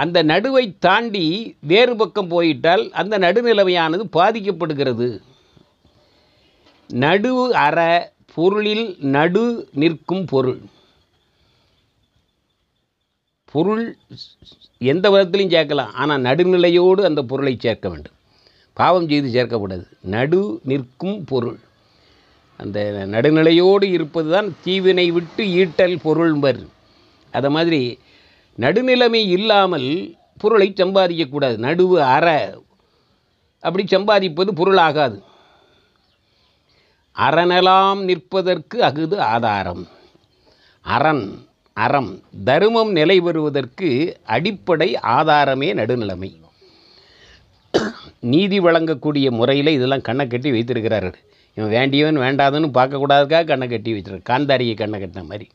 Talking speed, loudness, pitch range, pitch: 85 wpm, -17 LUFS, 125-185 Hz, 155 Hz